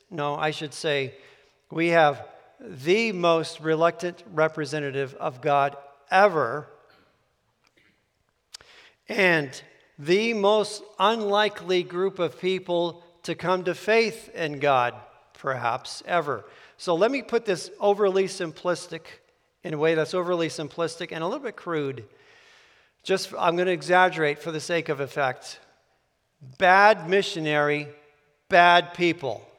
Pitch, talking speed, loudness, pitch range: 170 Hz, 120 wpm, -24 LUFS, 155-190 Hz